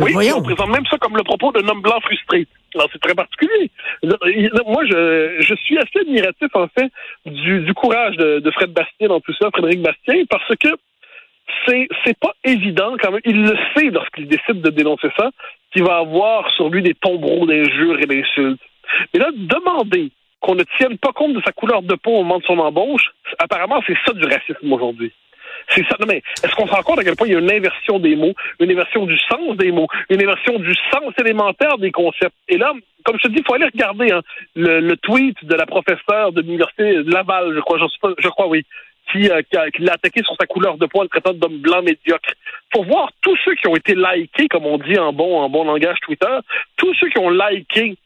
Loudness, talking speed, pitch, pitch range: -16 LUFS, 230 wpm, 195 Hz, 170-250 Hz